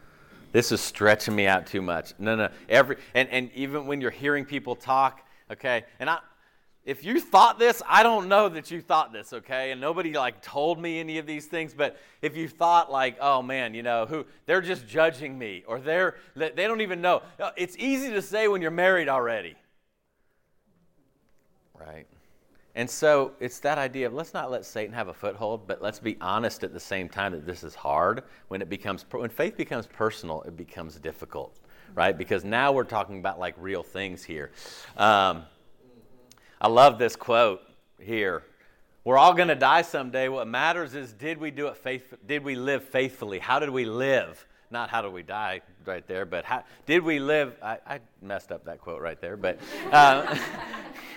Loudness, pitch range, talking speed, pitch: -25 LUFS, 105-155 Hz, 195 wpm, 130 Hz